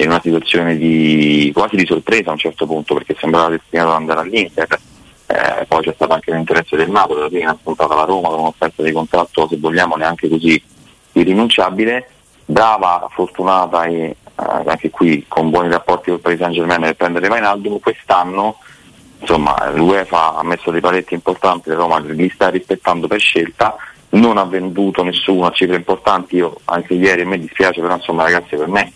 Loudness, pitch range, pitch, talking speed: -14 LUFS, 80-95 Hz, 85 Hz, 180 wpm